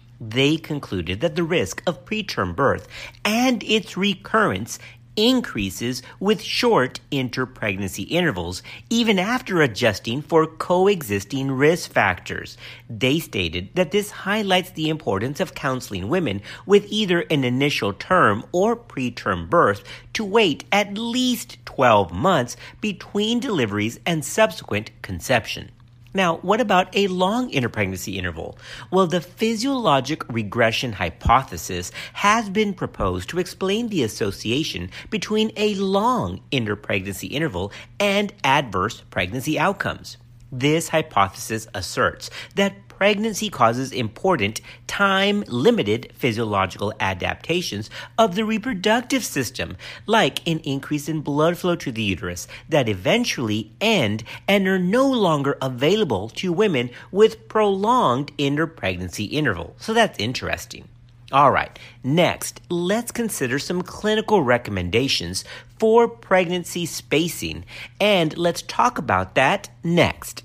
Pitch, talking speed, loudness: 145 Hz, 120 wpm, -21 LUFS